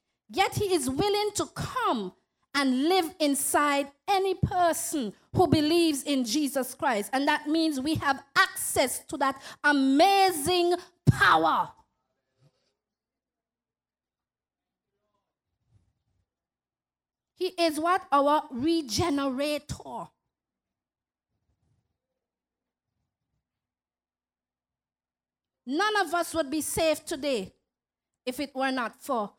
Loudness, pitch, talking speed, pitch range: -26 LUFS, 290 Hz, 90 wpm, 240-340 Hz